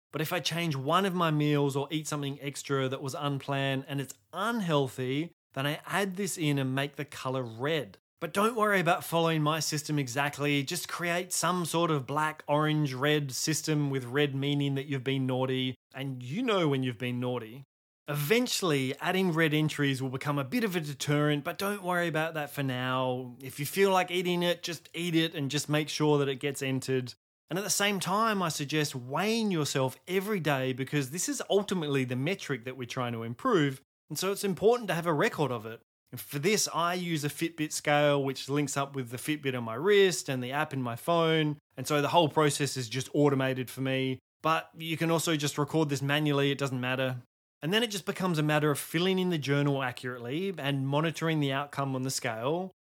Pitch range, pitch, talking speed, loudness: 135-170 Hz, 145 Hz, 215 wpm, -30 LUFS